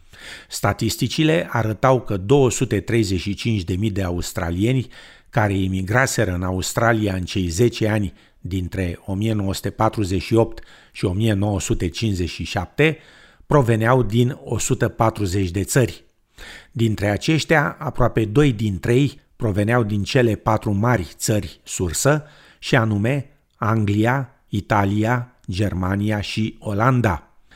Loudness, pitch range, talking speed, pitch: -21 LUFS, 100-120 Hz, 95 wpm, 110 Hz